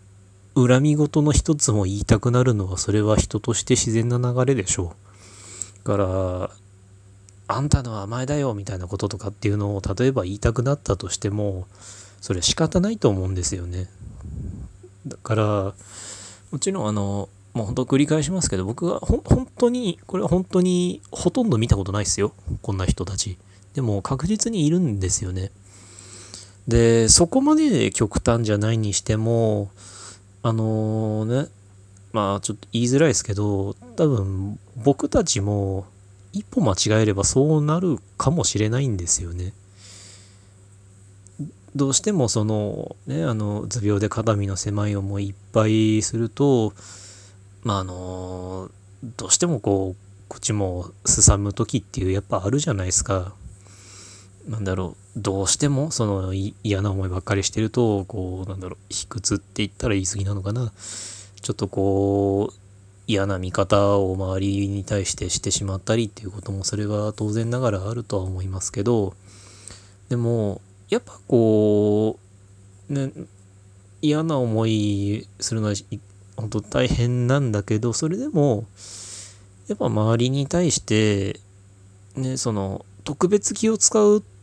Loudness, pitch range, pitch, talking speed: -22 LUFS, 100-120 Hz, 100 Hz, 295 characters per minute